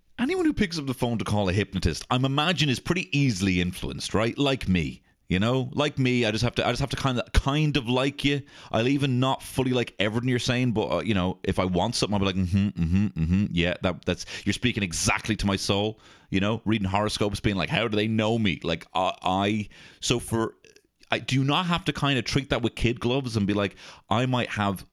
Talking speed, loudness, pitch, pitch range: 255 wpm, -26 LUFS, 115 Hz, 100-130 Hz